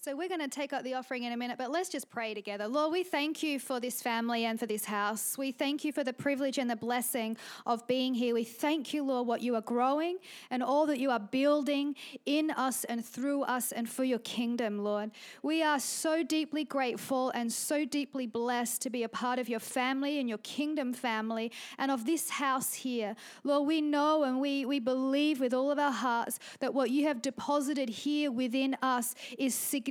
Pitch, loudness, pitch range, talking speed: 260 Hz, -32 LUFS, 240-290 Hz, 220 wpm